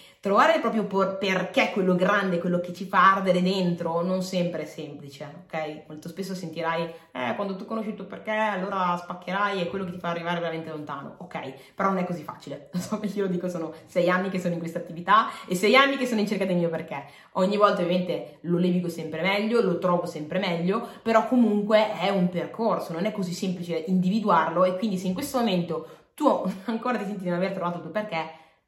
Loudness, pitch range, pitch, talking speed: -25 LUFS, 170-200 Hz, 185 Hz, 220 wpm